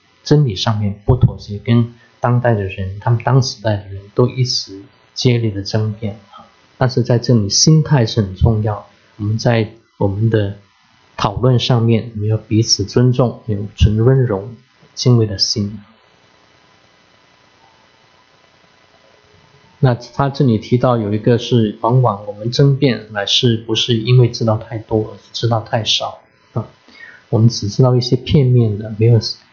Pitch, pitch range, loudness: 115 Hz, 105-125 Hz, -16 LUFS